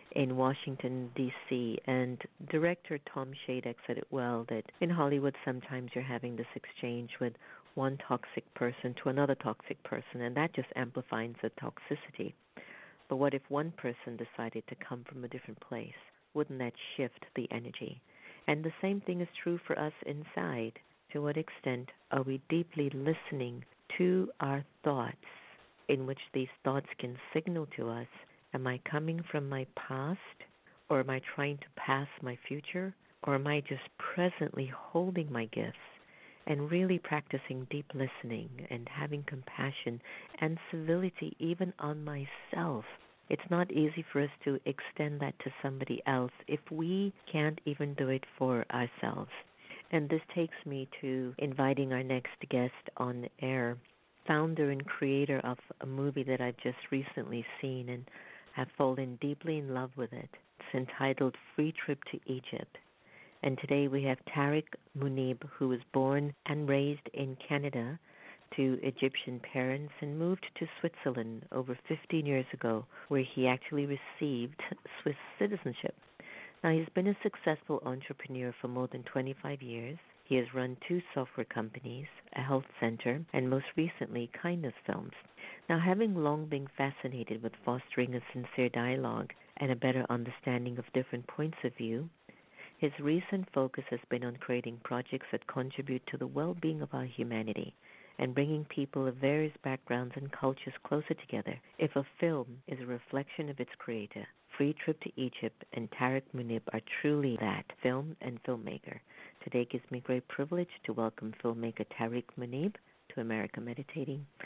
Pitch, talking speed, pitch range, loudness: 135 Hz, 160 wpm, 125-150 Hz, -36 LUFS